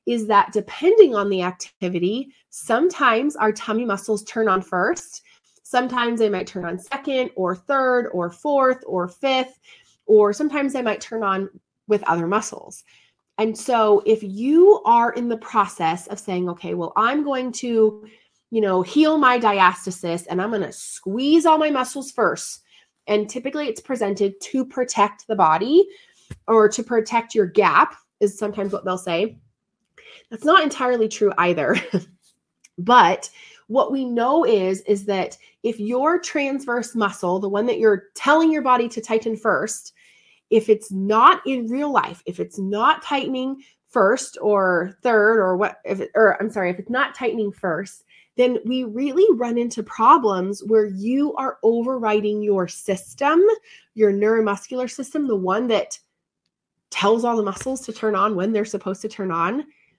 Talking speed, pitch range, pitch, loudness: 165 wpm, 200-260 Hz, 220 Hz, -20 LUFS